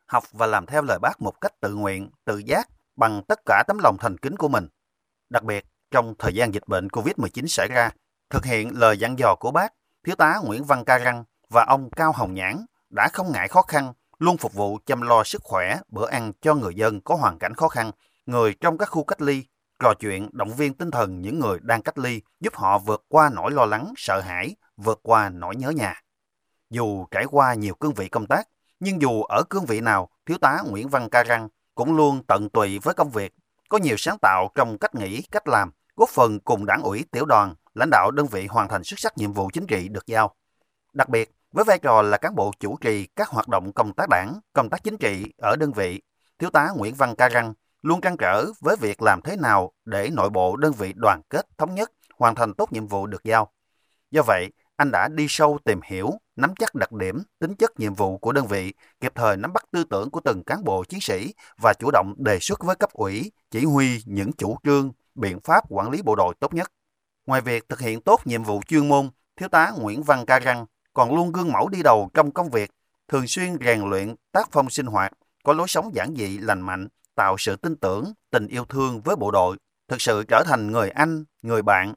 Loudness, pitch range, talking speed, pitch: -22 LUFS, 105-150 Hz, 235 wpm, 120 Hz